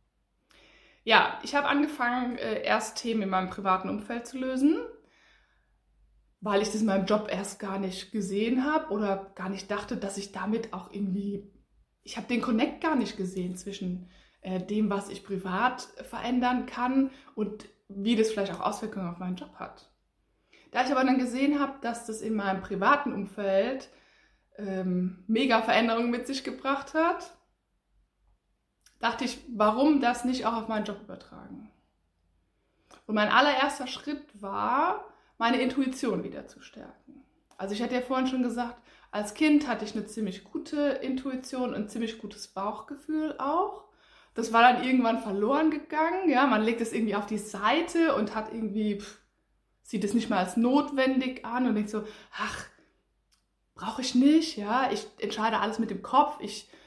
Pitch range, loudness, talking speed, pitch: 205-260 Hz, -28 LUFS, 165 wpm, 225 Hz